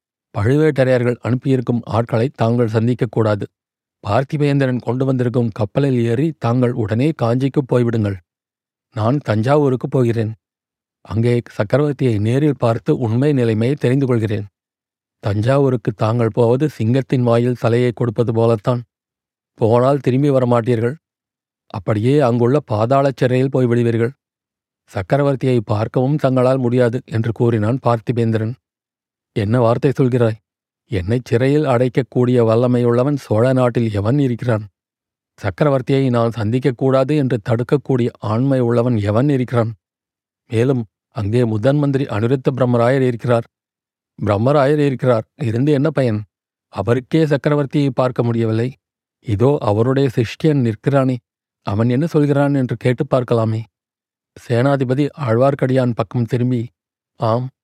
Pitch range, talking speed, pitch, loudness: 115-135 Hz, 105 wpm, 125 Hz, -17 LUFS